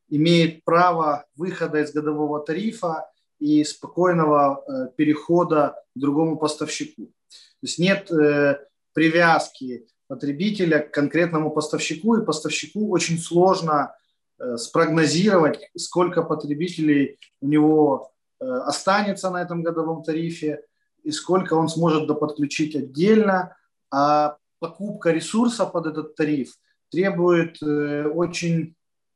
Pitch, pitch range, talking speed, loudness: 160 Hz, 150-175 Hz, 110 wpm, -22 LUFS